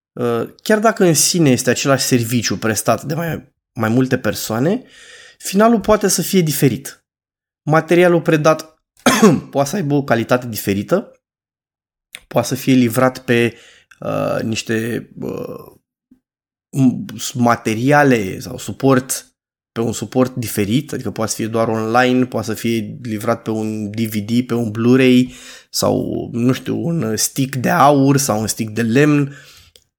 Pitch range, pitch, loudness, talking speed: 115-145 Hz, 125 Hz, -16 LUFS, 140 wpm